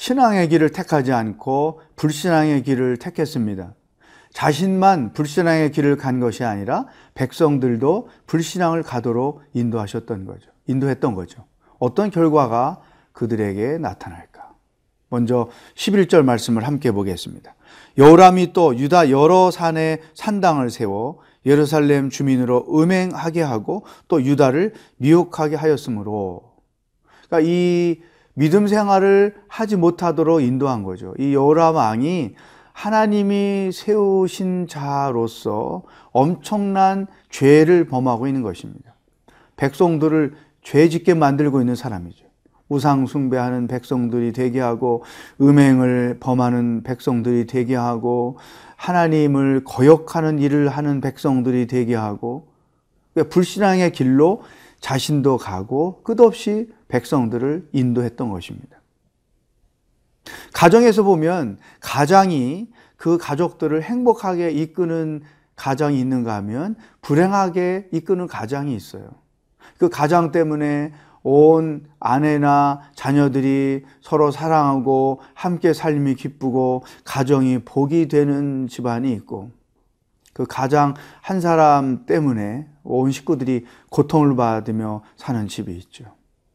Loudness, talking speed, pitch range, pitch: -18 LUFS, 265 characters per minute, 125-165 Hz, 145 Hz